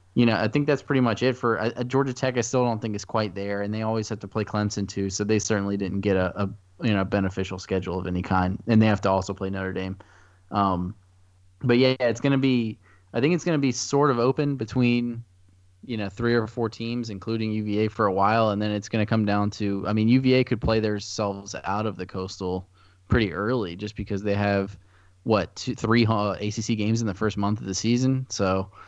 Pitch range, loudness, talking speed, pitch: 95-115 Hz, -25 LUFS, 240 wpm, 105 Hz